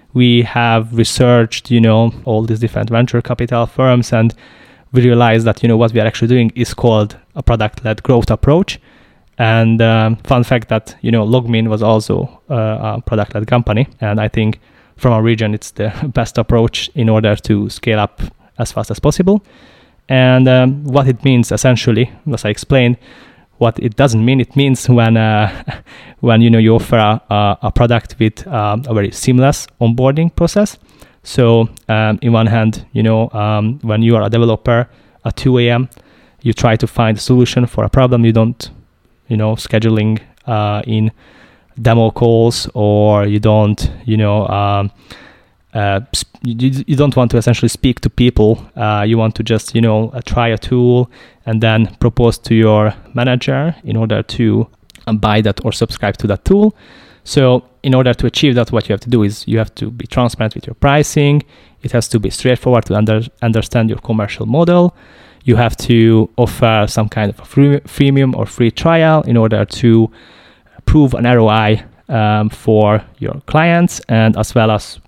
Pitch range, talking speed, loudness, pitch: 110-125 Hz, 185 wpm, -13 LUFS, 115 Hz